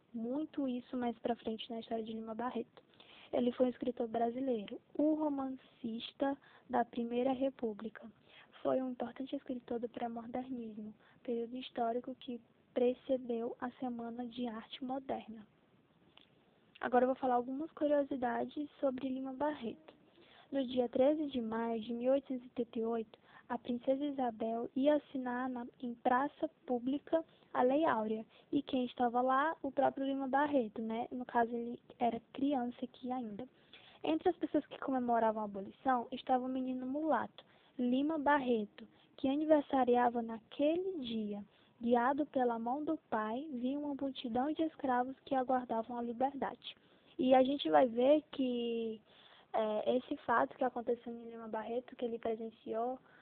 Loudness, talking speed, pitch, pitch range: -37 LUFS, 145 wpm, 250 Hz, 235-270 Hz